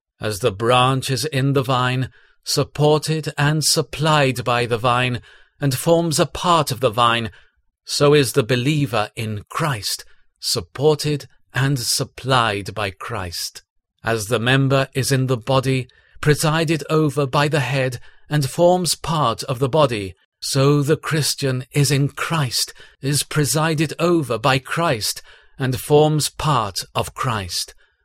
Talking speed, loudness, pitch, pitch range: 140 wpm, -19 LUFS, 135 Hz, 125-150 Hz